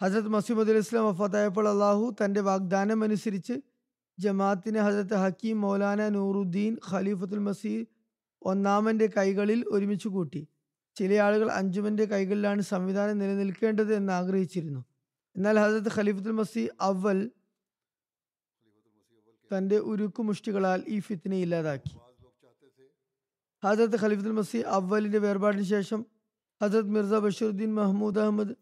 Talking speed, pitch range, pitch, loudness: 100 wpm, 195-215 Hz, 205 Hz, -28 LUFS